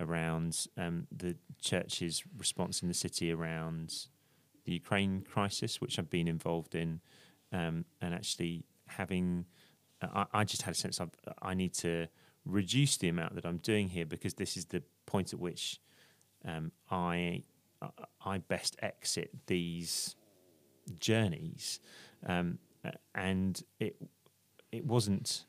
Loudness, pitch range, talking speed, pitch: -37 LUFS, 85-100 Hz, 135 wpm, 90 Hz